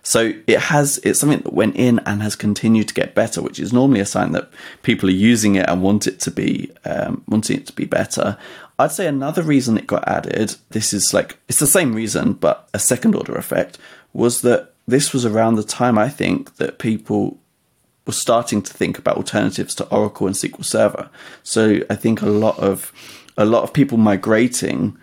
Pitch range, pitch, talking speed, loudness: 105-125 Hz, 110 Hz, 210 wpm, -18 LUFS